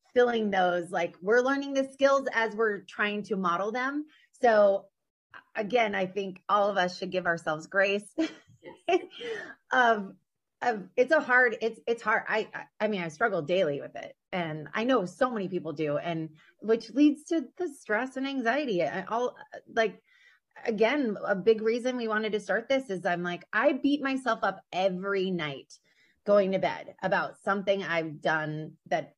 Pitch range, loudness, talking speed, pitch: 185-250 Hz, -28 LUFS, 175 wpm, 215 Hz